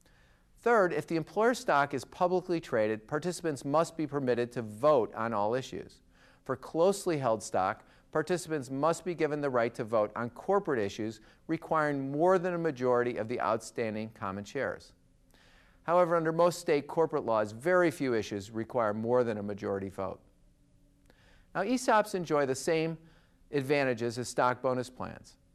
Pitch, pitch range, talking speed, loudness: 145 Hz, 115-165 Hz, 155 wpm, -31 LUFS